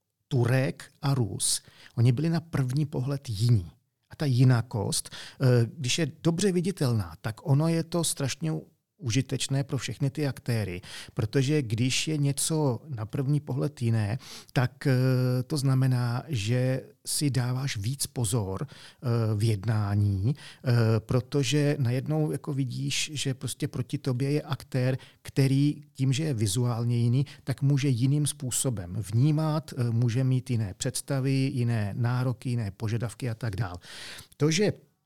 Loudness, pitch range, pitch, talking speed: -28 LUFS, 120-145 Hz, 130 Hz, 135 wpm